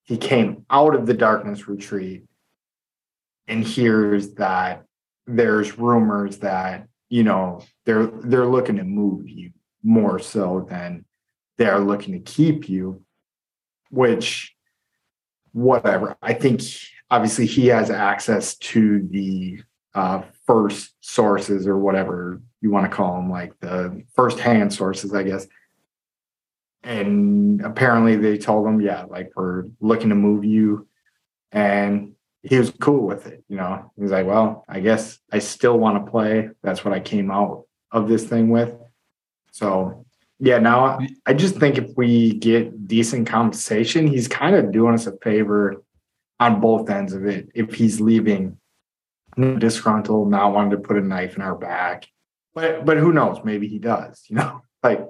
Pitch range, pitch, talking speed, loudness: 100-120 Hz, 110 Hz, 155 wpm, -20 LUFS